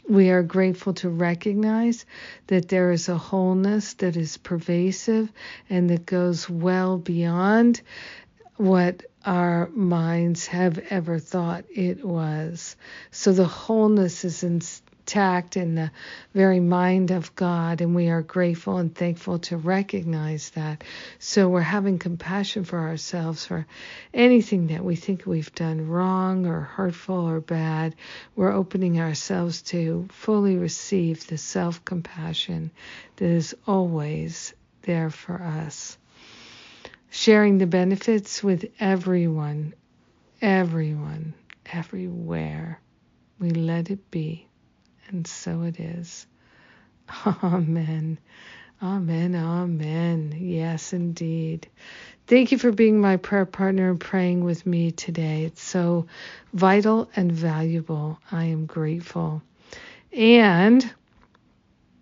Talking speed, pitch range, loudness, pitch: 115 wpm, 165-190 Hz, -23 LUFS, 175 Hz